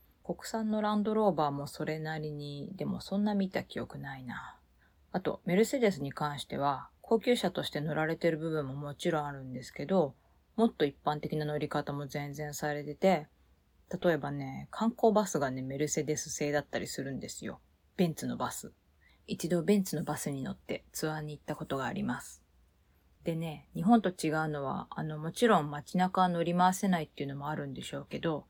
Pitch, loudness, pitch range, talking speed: 155 Hz, -33 LUFS, 145-185 Hz, 375 characters per minute